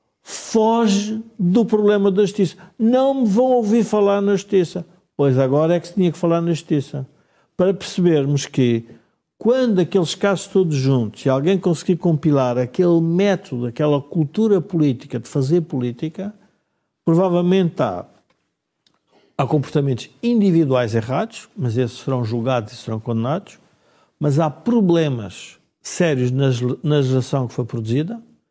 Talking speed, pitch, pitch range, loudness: 135 wpm, 165 Hz, 135-195 Hz, -19 LUFS